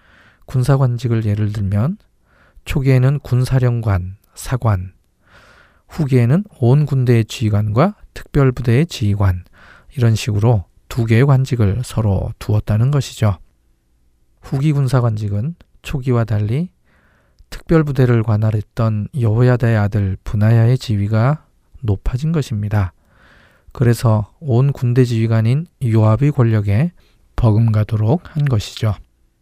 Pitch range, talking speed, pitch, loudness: 105-130 Hz, 255 characters per minute, 115 Hz, -17 LUFS